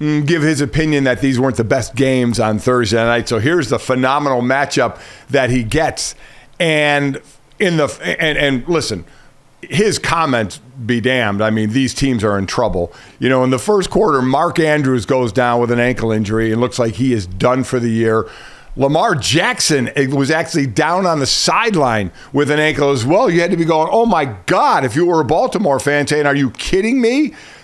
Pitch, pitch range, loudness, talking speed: 135 Hz, 125-155 Hz, -15 LUFS, 200 wpm